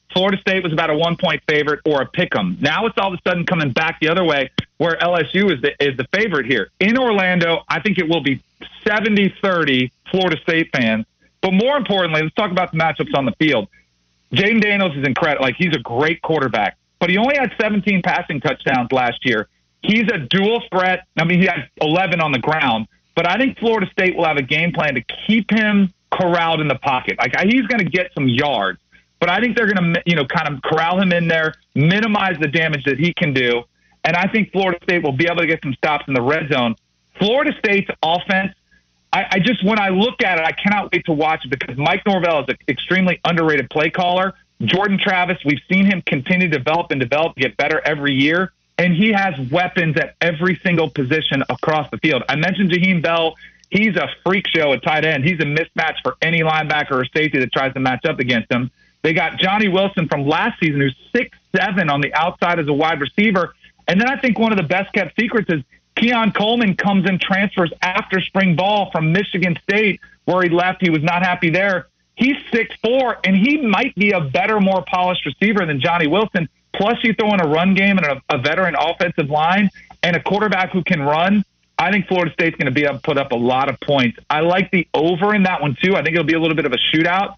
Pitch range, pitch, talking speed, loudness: 155-195 Hz, 175 Hz, 225 wpm, -17 LUFS